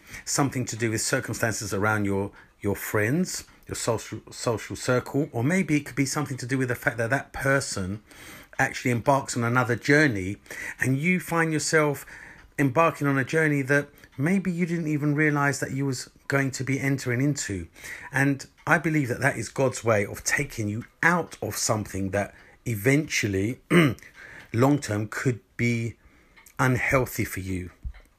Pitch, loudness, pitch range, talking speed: 135 Hz, -25 LUFS, 110-145 Hz, 165 wpm